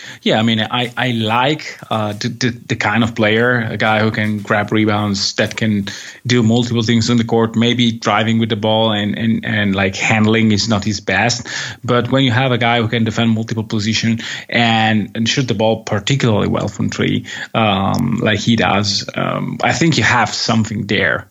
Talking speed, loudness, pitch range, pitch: 200 wpm, -15 LUFS, 110-120 Hz, 115 Hz